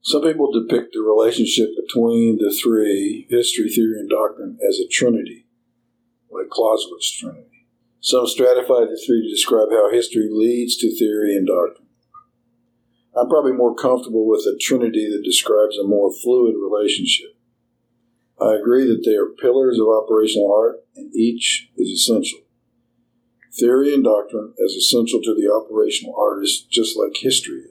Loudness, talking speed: -17 LUFS, 150 wpm